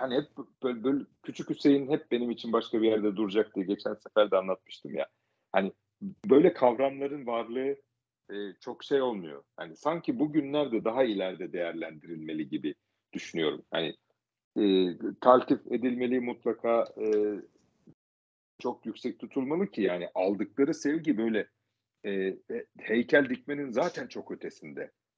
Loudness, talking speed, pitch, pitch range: -30 LUFS, 135 wpm, 115 Hz, 100-140 Hz